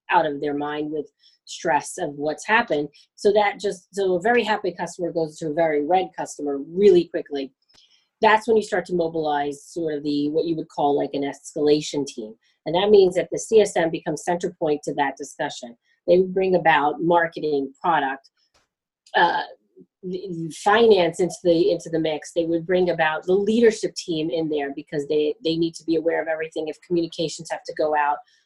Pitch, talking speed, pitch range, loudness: 165 Hz, 190 wpm, 150-180 Hz, -22 LUFS